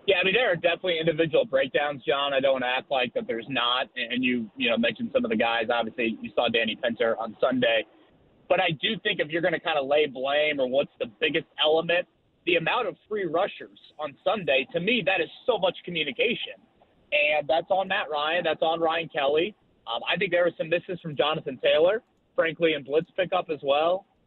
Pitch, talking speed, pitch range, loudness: 165 Hz, 220 wpm, 145-195 Hz, -25 LUFS